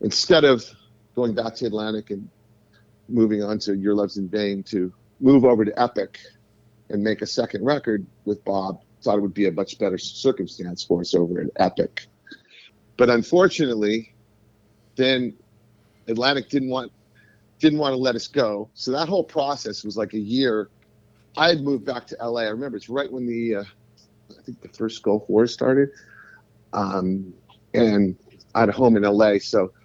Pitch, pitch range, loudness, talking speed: 110 Hz, 105-120 Hz, -22 LUFS, 175 wpm